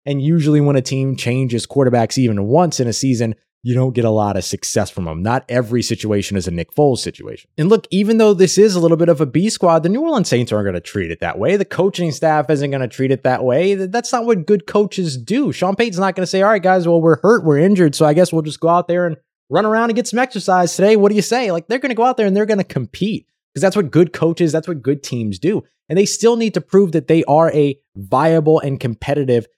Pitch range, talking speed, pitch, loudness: 130-195 Hz, 280 wpm, 160 Hz, -16 LUFS